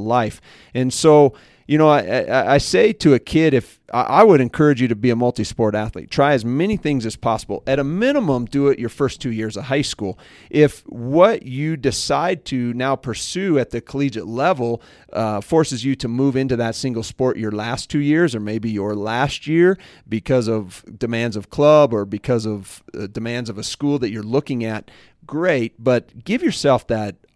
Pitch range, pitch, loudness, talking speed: 110-145 Hz, 125 Hz, -19 LUFS, 195 wpm